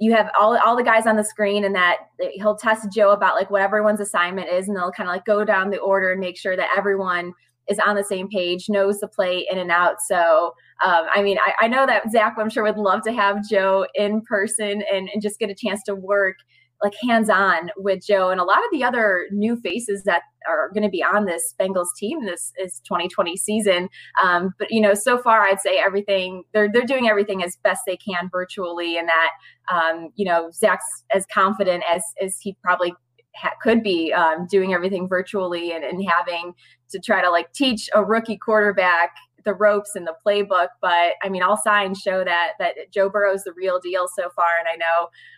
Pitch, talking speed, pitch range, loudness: 195 Hz, 220 wpm, 180-210 Hz, -20 LUFS